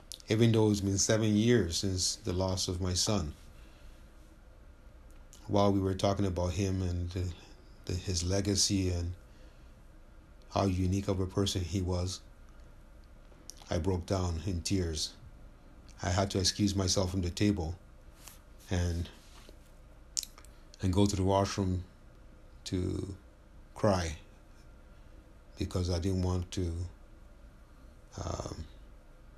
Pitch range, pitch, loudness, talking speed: 85-100 Hz, 95 Hz, -32 LUFS, 120 wpm